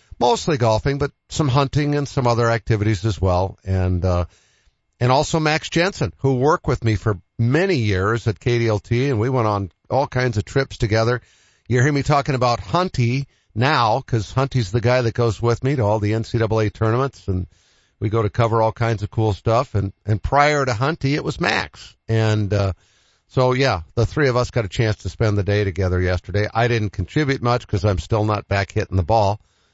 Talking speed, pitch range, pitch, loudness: 205 wpm, 105-130 Hz, 115 Hz, -20 LUFS